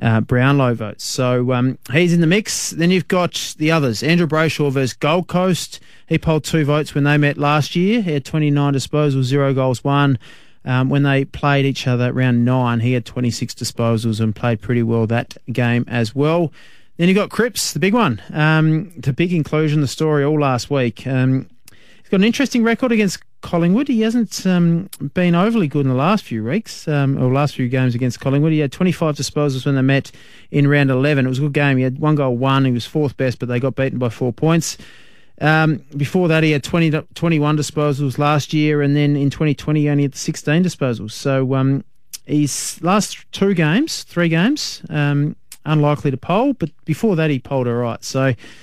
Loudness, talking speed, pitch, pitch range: -17 LUFS, 210 wpm, 145 Hz, 130-165 Hz